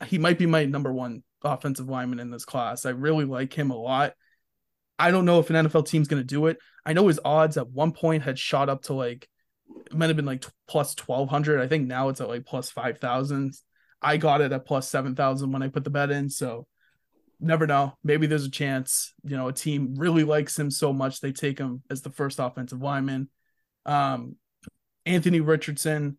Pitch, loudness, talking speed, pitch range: 140 Hz, -25 LUFS, 215 wpm, 130-155 Hz